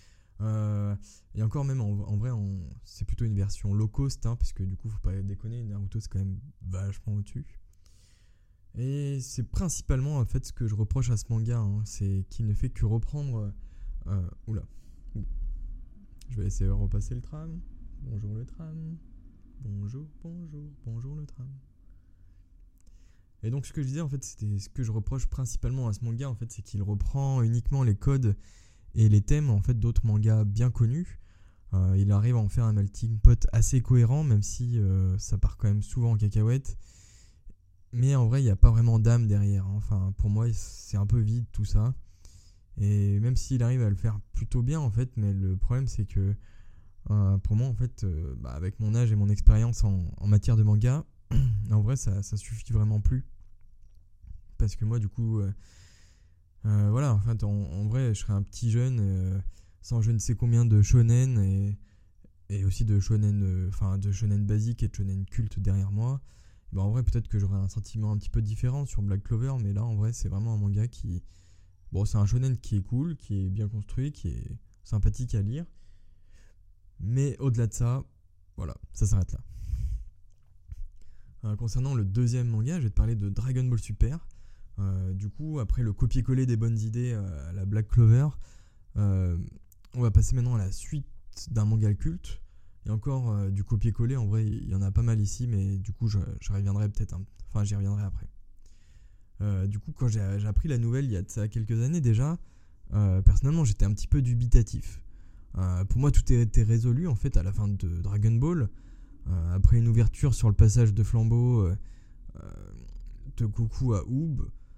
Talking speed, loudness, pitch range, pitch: 200 wpm, -28 LUFS, 95-120 Hz, 105 Hz